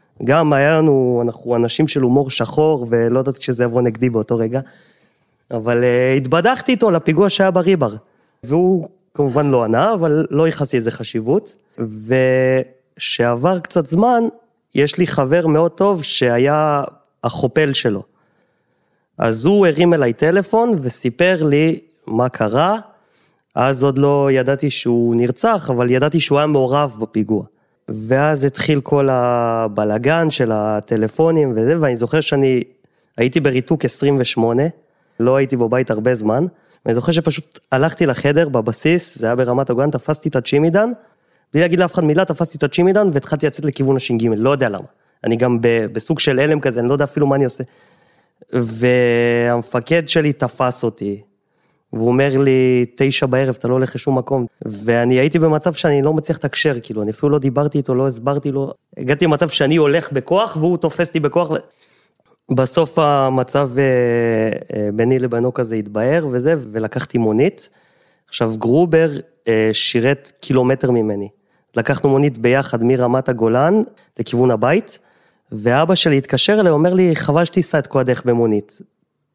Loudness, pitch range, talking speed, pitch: -16 LUFS, 120-160 Hz, 150 wpm, 135 Hz